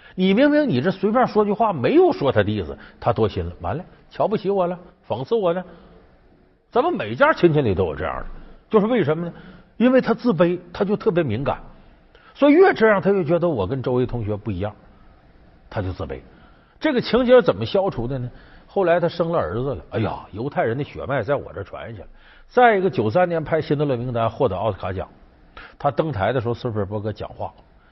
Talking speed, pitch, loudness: 320 characters per minute, 175 Hz, -21 LUFS